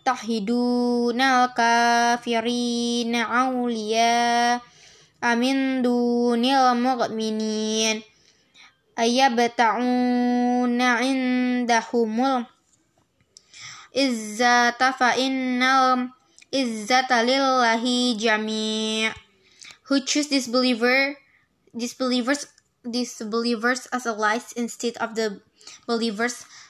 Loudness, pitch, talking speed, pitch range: -22 LUFS, 240 Hz, 60 wpm, 230-255 Hz